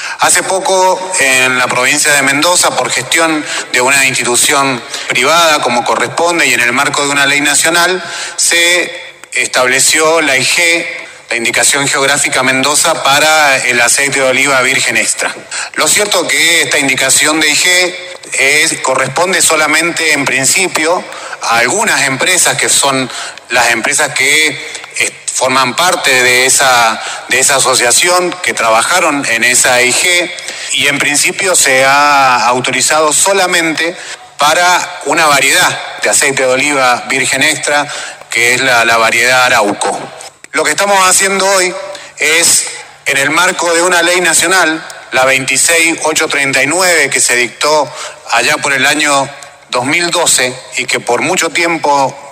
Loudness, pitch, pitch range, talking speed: -9 LUFS, 145 Hz, 130-170 Hz, 140 wpm